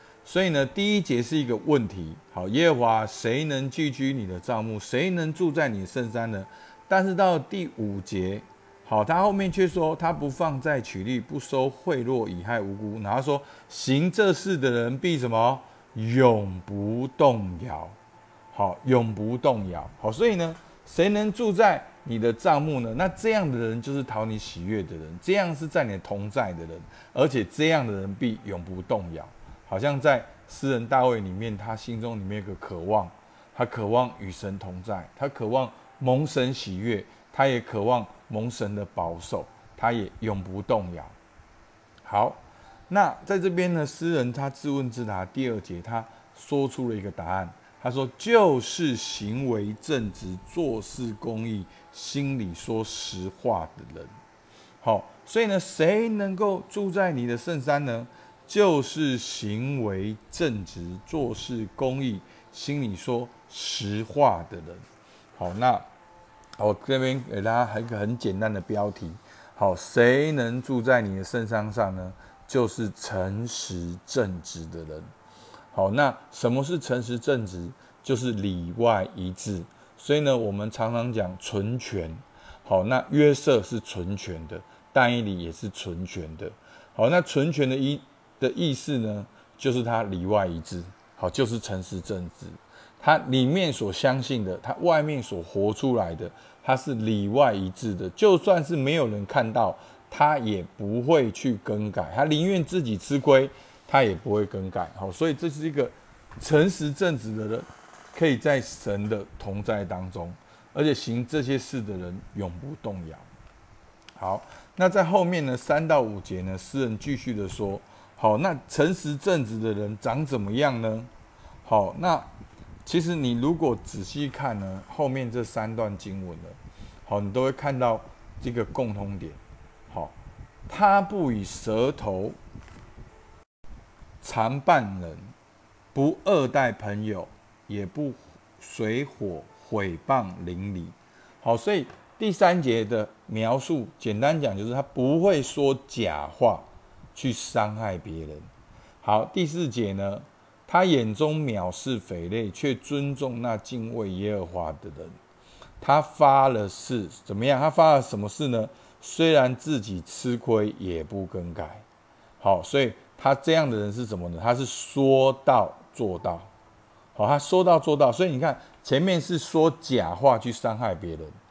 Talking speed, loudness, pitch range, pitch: 220 characters per minute, -26 LUFS, 100-140 Hz, 115 Hz